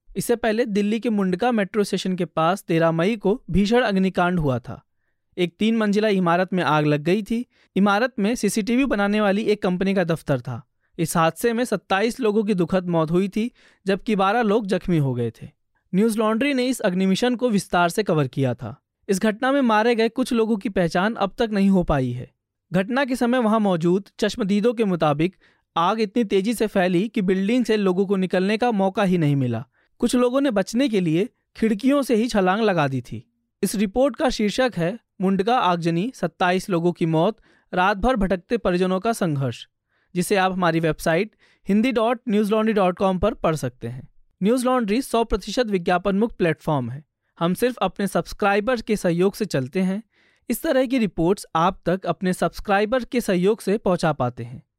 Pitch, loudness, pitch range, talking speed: 195 Hz, -22 LUFS, 175-225 Hz, 195 wpm